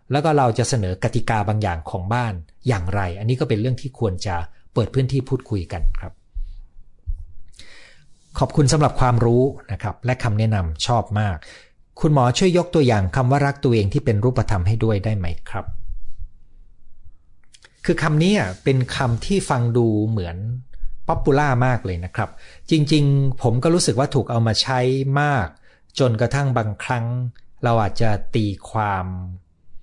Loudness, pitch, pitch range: -20 LUFS, 115 Hz, 95-130 Hz